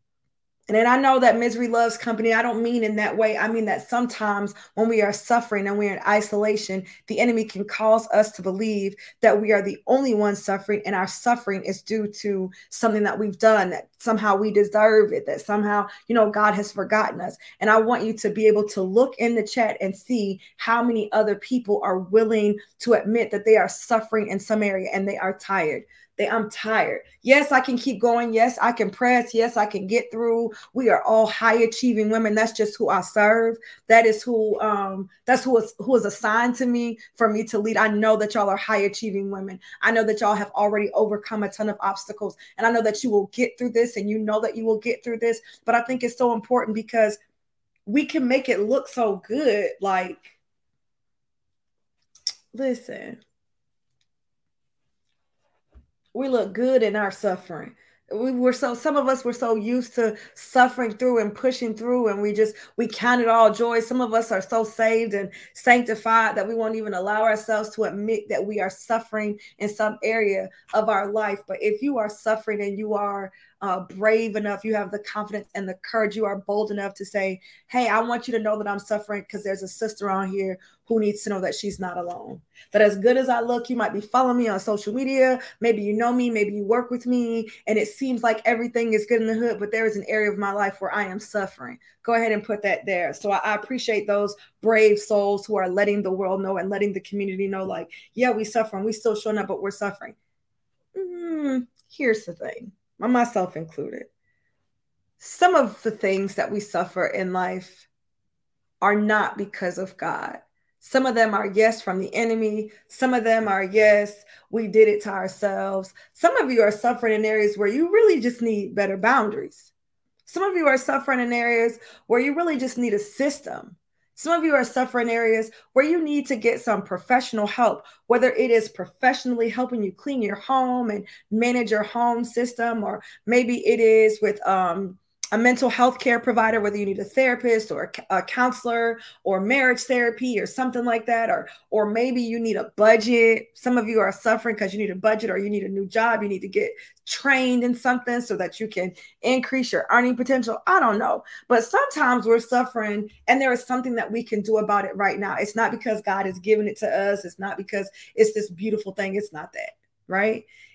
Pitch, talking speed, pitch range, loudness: 220 Hz, 215 wpm, 205-240 Hz, -22 LUFS